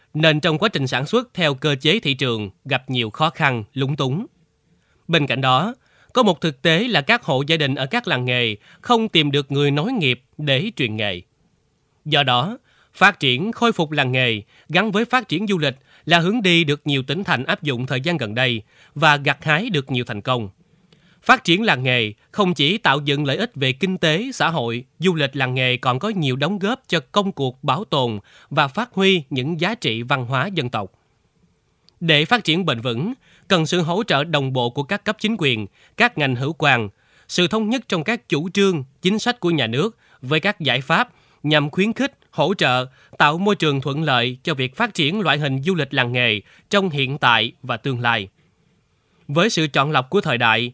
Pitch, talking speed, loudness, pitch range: 150 Hz, 220 wpm, -19 LUFS, 130-185 Hz